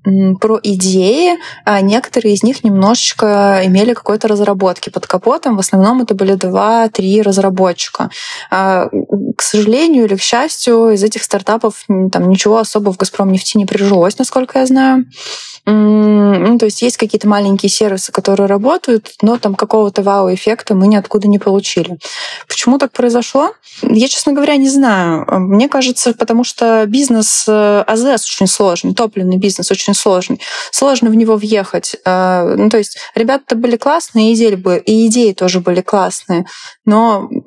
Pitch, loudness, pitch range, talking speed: 215 Hz, -11 LUFS, 195-240 Hz, 140 wpm